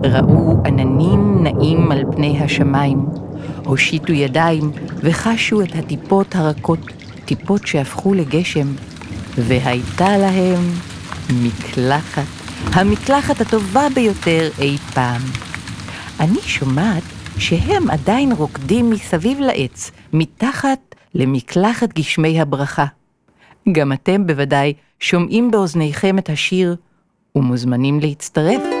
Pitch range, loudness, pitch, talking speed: 135-185 Hz, -16 LUFS, 155 Hz, 90 wpm